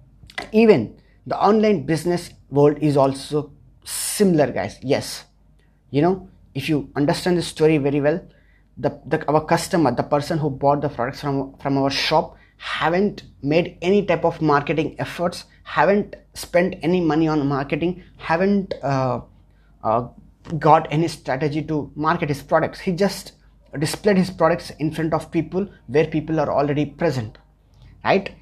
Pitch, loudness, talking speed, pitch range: 155 Hz, -21 LUFS, 150 wpm, 140-170 Hz